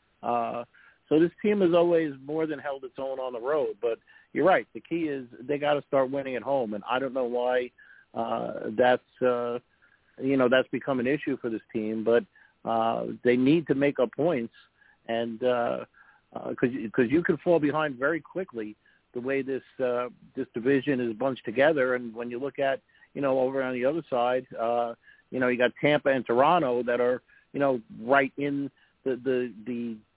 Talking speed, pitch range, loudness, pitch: 200 wpm, 120-140 Hz, -27 LUFS, 130 Hz